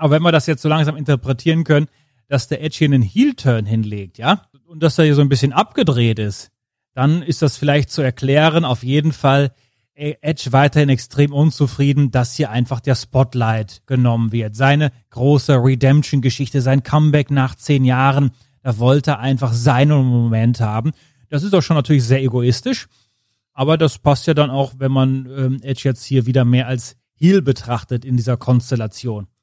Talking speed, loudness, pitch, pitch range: 175 wpm, -16 LUFS, 135 Hz, 125-150 Hz